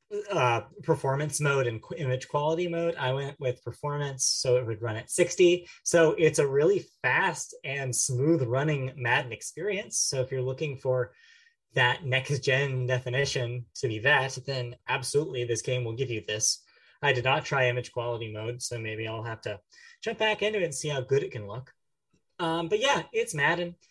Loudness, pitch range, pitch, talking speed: -28 LUFS, 125-165 Hz, 135 Hz, 190 wpm